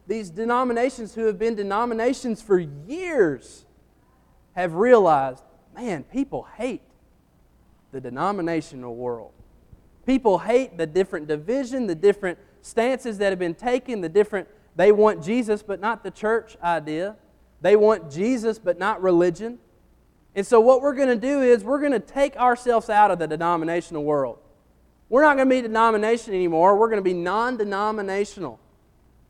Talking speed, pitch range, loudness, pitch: 150 wpm, 175-235 Hz, -22 LUFS, 210 Hz